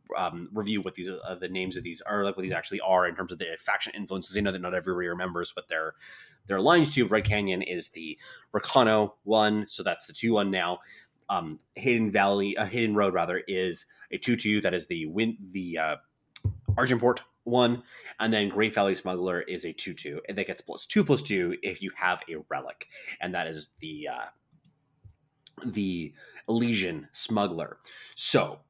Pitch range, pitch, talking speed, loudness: 90-110 Hz, 100 Hz, 200 wpm, -28 LUFS